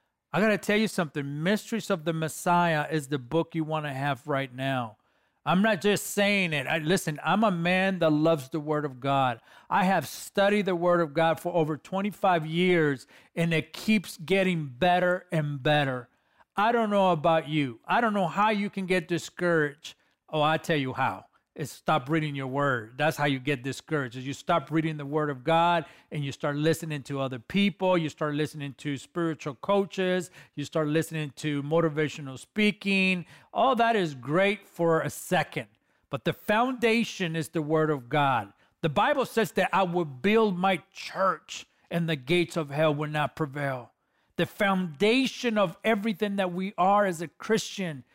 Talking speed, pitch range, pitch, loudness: 185 wpm, 150-190 Hz, 165 Hz, -27 LUFS